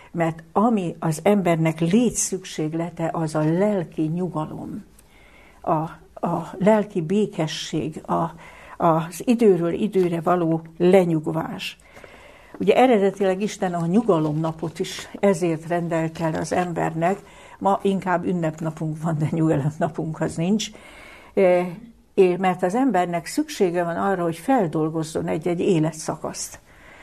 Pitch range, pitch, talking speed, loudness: 165-195 Hz, 175 Hz, 110 wpm, -22 LUFS